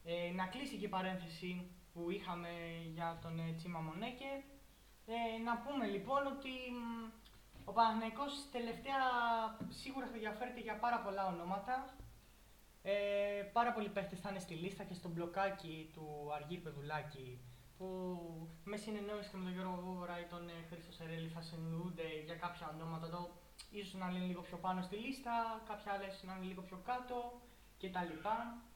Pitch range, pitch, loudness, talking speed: 170-230 Hz, 185 Hz, -43 LUFS, 160 wpm